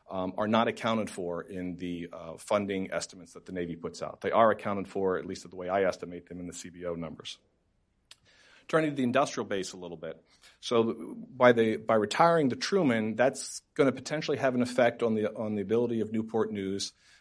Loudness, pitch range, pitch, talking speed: -29 LUFS, 90-120 Hz, 105 Hz, 215 wpm